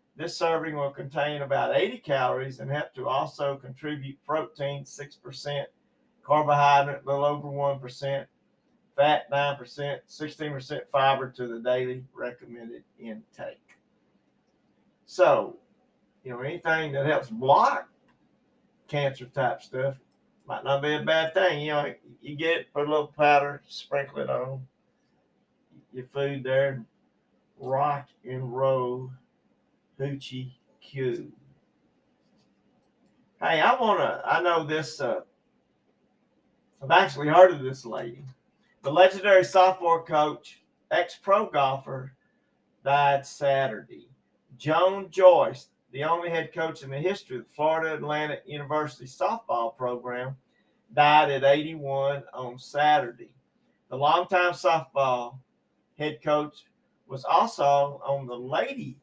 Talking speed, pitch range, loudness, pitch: 120 wpm, 135-155 Hz, -26 LUFS, 140 Hz